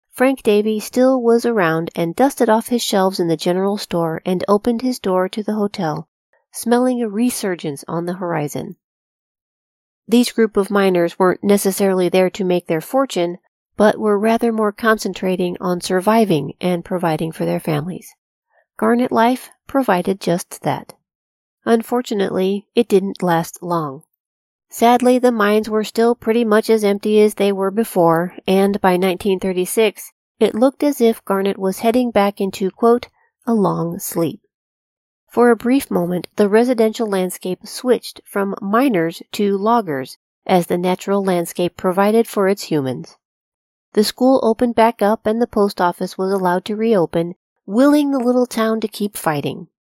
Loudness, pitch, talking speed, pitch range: -17 LUFS, 200 Hz, 155 wpm, 180-230 Hz